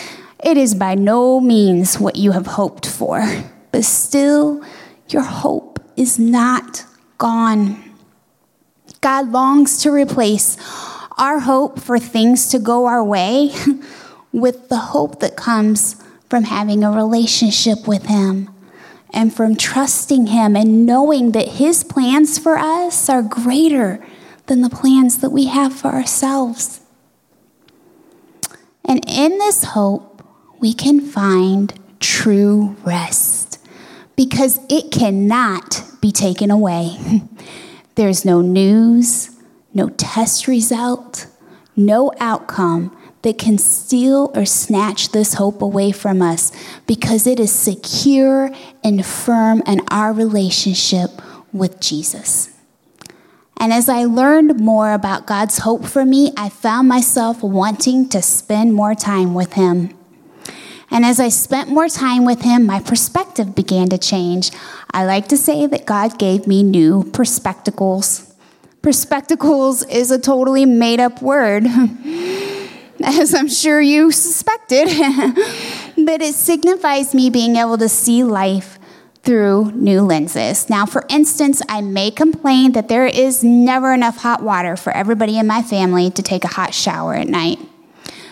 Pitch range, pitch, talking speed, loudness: 205-270 Hz, 235 Hz, 135 wpm, -14 LUFS